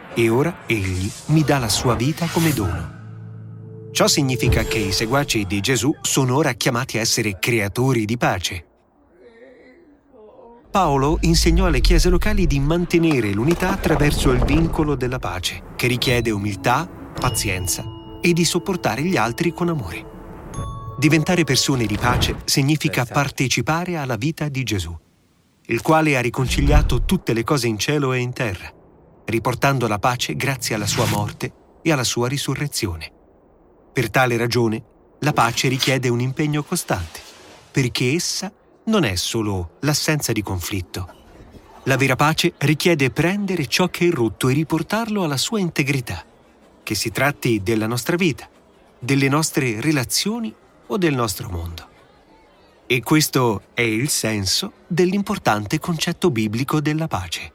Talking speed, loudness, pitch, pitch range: 140 wpm, -20 LUFS, 130 Hz, 110-160 Hz